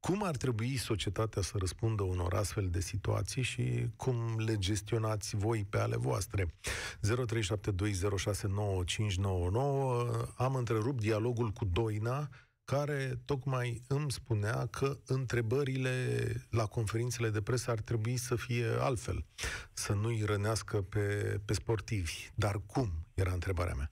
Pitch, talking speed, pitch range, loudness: 115 Hz, 125 wpm, 105-125 Hz, -35 LUFS